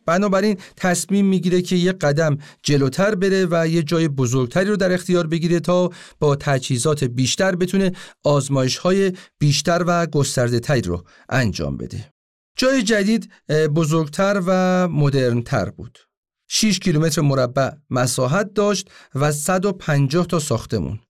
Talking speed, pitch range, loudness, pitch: 130 wpm, 135-185 Hz, -19 LUFS, 165 Hz